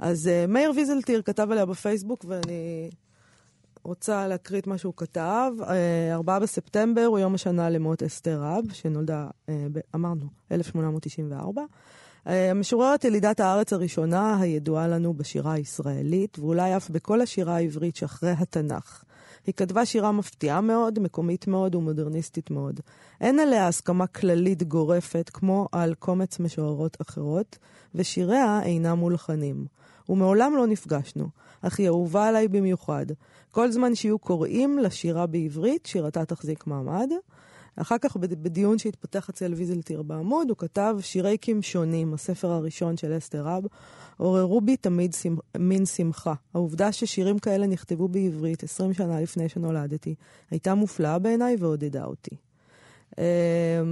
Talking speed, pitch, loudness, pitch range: 125 wpm, 180 Hz, -26 LUFS, 165-200 Hz